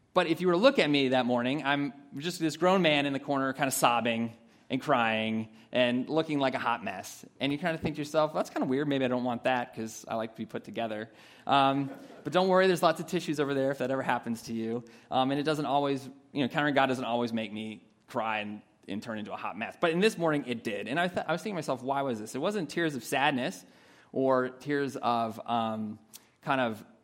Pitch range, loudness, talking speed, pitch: 115-155 Hz, -30 LUFS, 260 wpm, 135 Hz